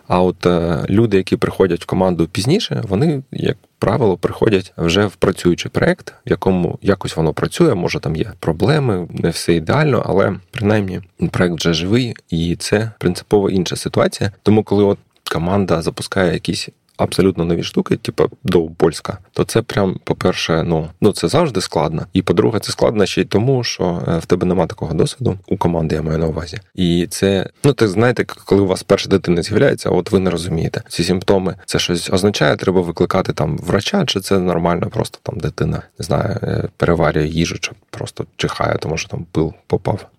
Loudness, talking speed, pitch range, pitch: -17 LUFS, 180 wpm, 85-105 Hz, 95 Hz